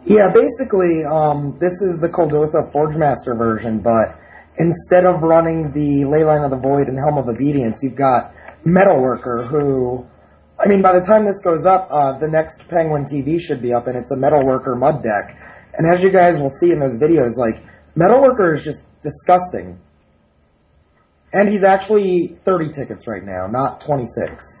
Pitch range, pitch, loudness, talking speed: 125-175 Hz, 150 Hz, -16 LUFS, 175 wpm